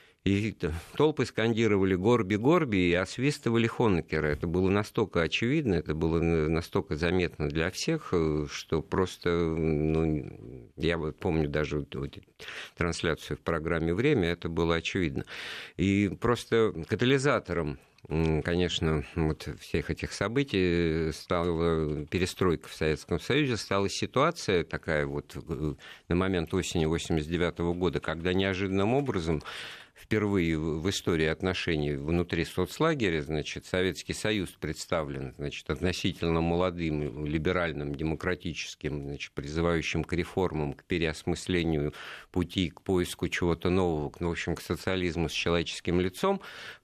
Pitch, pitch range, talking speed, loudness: 85 Hz, 80-95 Hz, 115 wpm, -29 LUFS